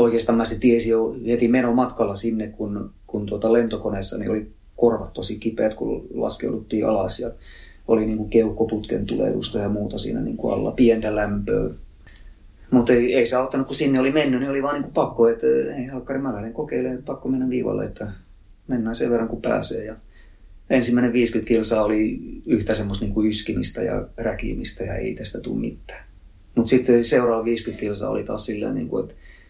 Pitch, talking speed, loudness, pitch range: 115 Hz, 180 wpm, -22 LUFS, 105-125 Hz